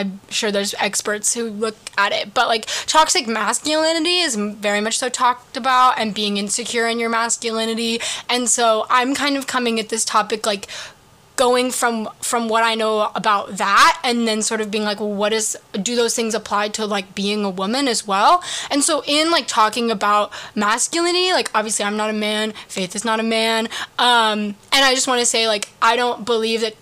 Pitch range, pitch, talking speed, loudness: 215-245 Hz, 225 Hz, 205 wpm, -18 LUFS